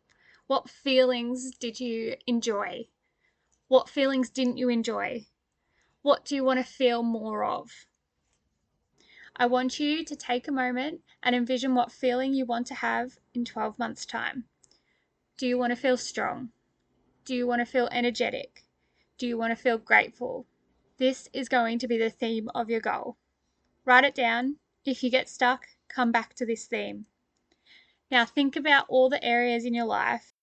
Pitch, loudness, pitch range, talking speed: 250 Hz, -27 LUFS, 235-260 Hz, 170 wpm